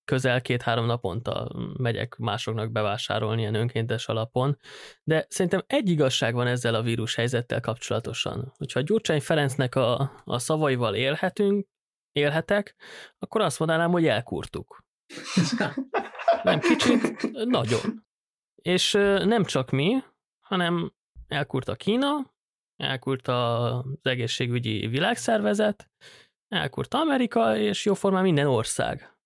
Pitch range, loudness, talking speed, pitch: 120-195 Hz, -26 LUFS, 110 wpm, 140 Hz